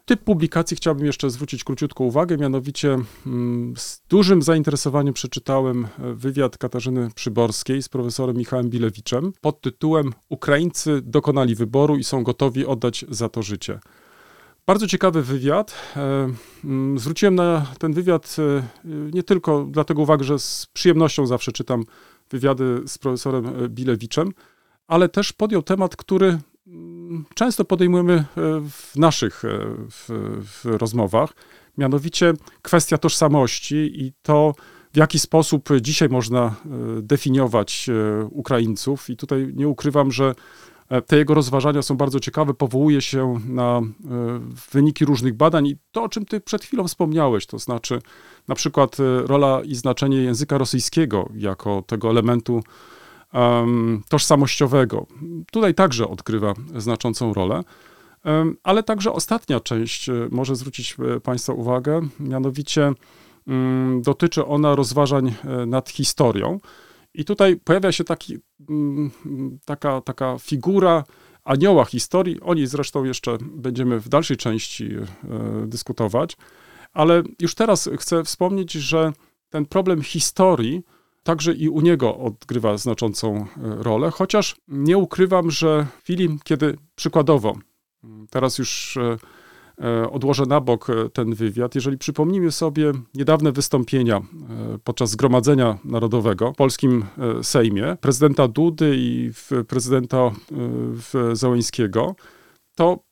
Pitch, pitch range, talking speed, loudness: 140 Hz, 120-155 Hz, 115 wpm, -20 LUFS